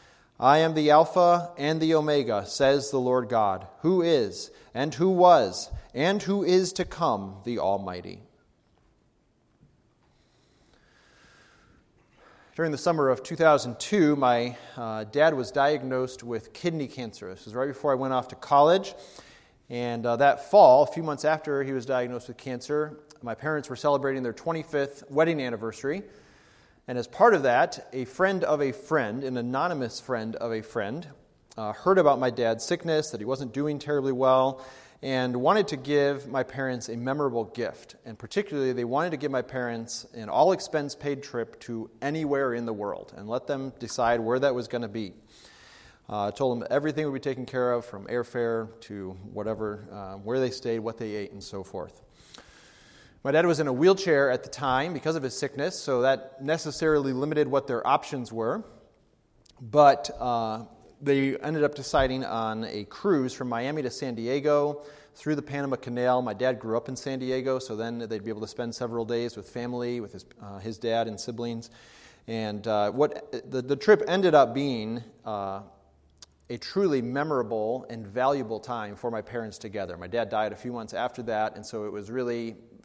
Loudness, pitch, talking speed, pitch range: -27 LUFS, 130 Hz, 185 wpm, 115-145 Hz